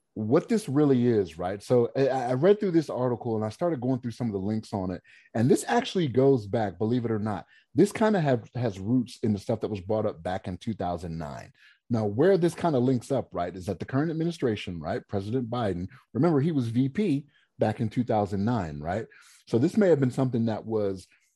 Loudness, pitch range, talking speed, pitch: -27 LUFS, 105-135 Hz, 220 wpm, 120 Hz